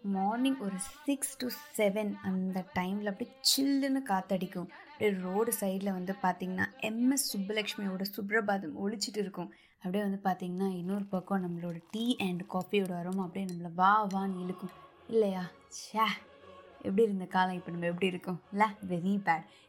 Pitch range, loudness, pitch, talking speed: 185-215 Hz, -33 LUFS, 195 Hz, 145 wpm